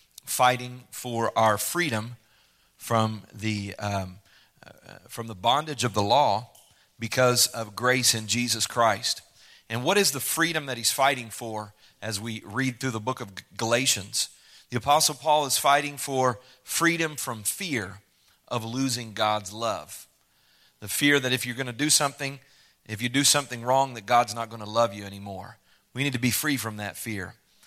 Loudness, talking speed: -25 LUFS, 175 wpm